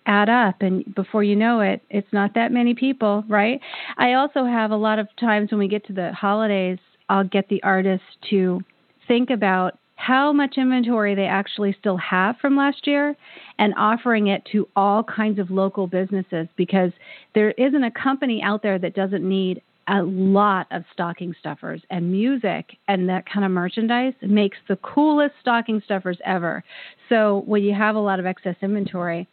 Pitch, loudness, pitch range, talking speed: 205 Hz, -21 LUFS, 190-230 Hz, 185 wpm